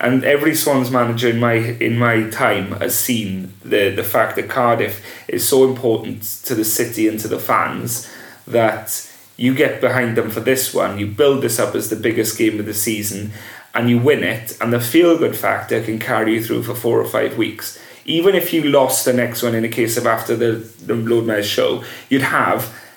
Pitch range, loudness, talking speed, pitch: 110-125 Hz, -17 LUFS, 210 wpm, 115 Hz